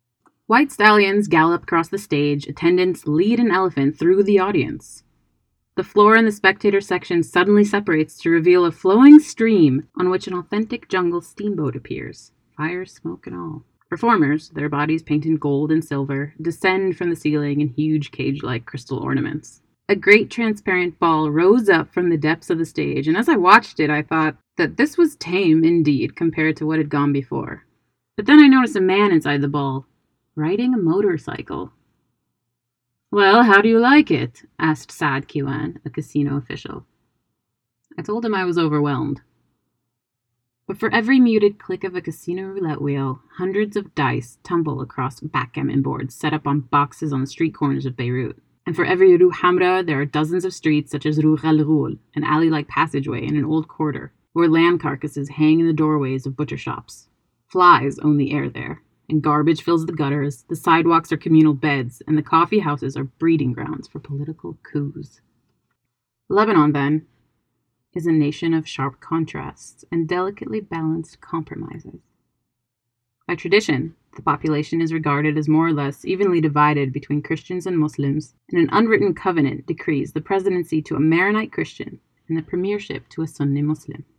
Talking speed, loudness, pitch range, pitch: 175 wpm, -19 LUFS, 145-180 Hz, 155 Hz